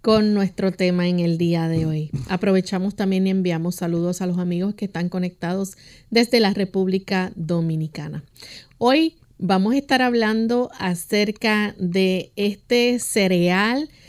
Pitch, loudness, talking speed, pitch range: 190 Hz, -21 LUFS, 135 wpm, 175-210 Hz